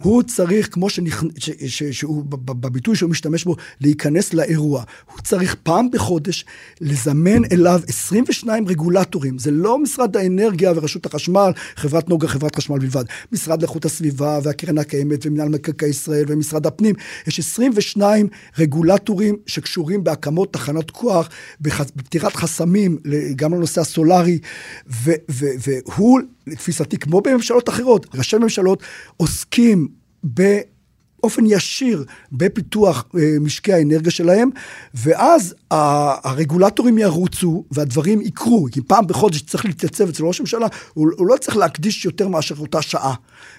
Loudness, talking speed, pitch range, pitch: -18 LUFS, 130 wpm, 150-200 Hz, 170 Hz